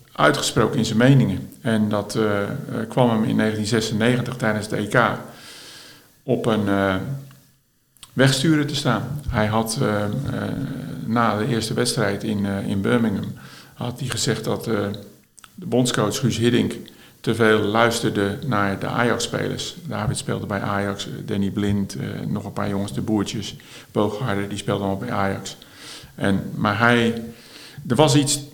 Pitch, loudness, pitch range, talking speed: 110 Hz, -22 LUFS, 100-125 Hz, 155 wpm